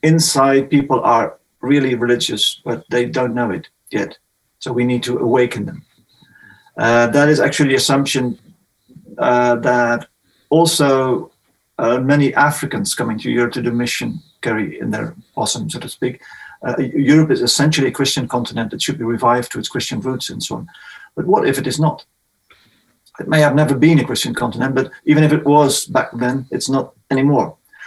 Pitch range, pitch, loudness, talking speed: 120-145 Hz, 135 Hz, -16 LUFS, 180 wpm